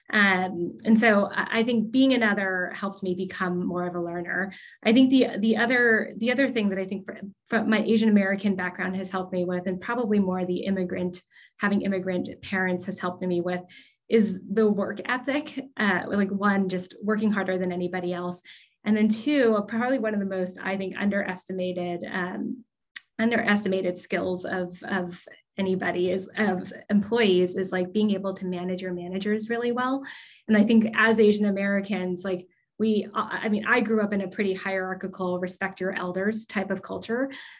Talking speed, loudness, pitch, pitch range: 180 wpm, -25 LUFS, 195 Hz, 185-220 Hz